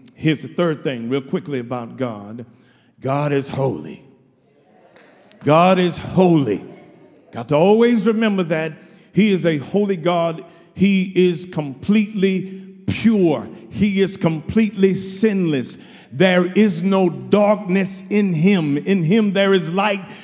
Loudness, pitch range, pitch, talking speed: -18 LUFS, 155-195 Hz, 180 Hz, 125 wpm